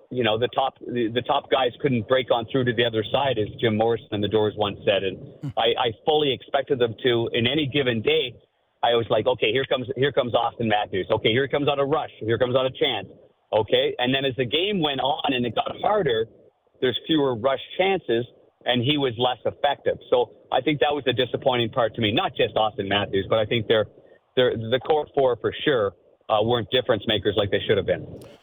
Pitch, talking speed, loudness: 135 Hz, 230 wpm, -23 LUFS